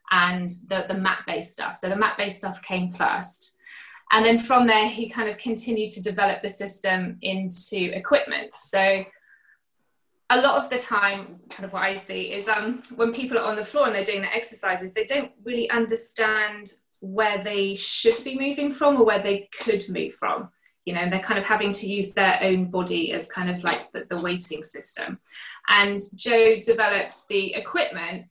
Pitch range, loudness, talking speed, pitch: 190-230 Hz, -23 LUFS, 190 wpm, 205 Hz